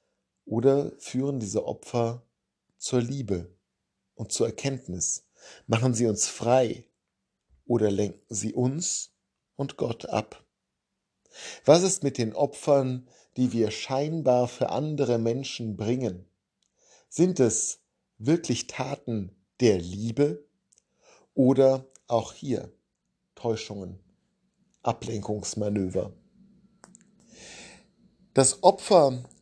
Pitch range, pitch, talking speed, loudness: 110-145 Hz, 125 Hz, 90 wpm, -26 LUFS